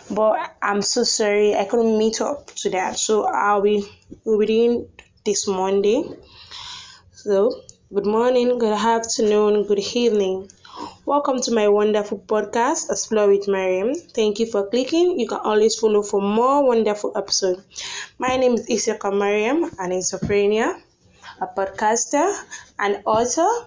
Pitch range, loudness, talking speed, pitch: 205-245 Hz, -20 LUFS, 135 wpm, 215 Hz